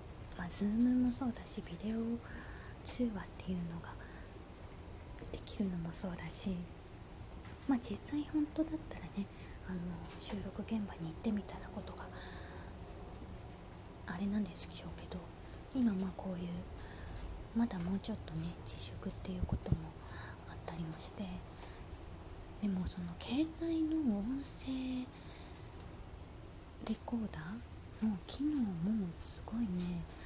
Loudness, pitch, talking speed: -40 LUFS, 115 Hz, 235 characters per minute